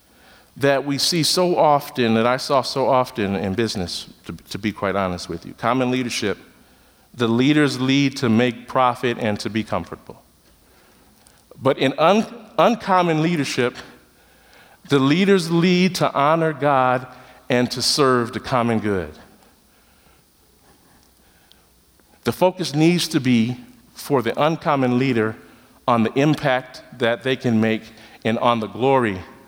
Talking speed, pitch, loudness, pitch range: 140 wpm, 125 Hz, -20 LUFS, 115-145 Hz